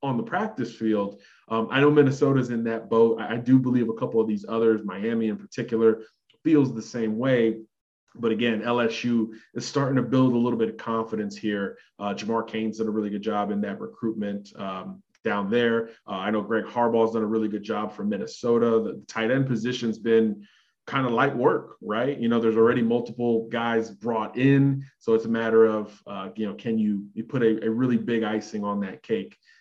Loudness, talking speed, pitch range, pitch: -25 LUFS, 210 wpm, 110-120 Hz, 115 Hz